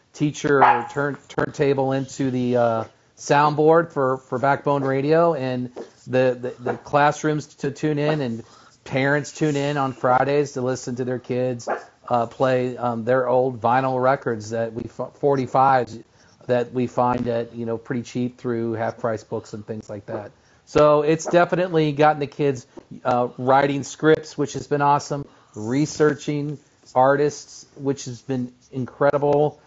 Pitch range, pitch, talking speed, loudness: 125-145 Hz, 130 Hz, 150 wpm, -22 LUFS